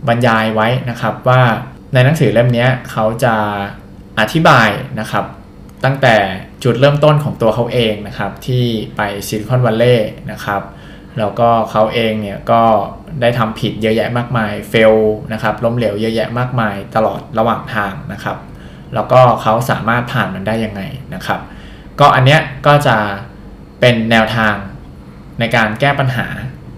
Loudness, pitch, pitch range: -14 LUFS, 110 Hz, 105-125 Hz